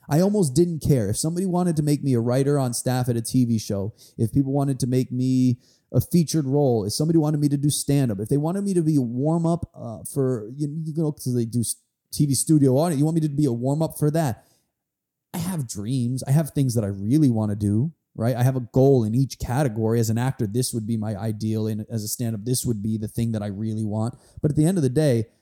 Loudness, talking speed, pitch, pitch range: -23 LUFS, 270 wpm, 130 Hz, 115-150 Hz